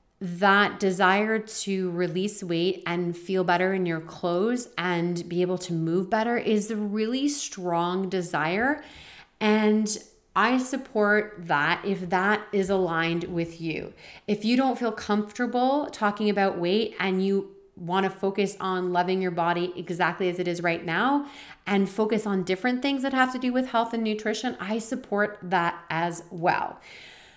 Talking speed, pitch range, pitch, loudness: 160 wpm, 180-220 Hz, 195 Hz, -26 LUFS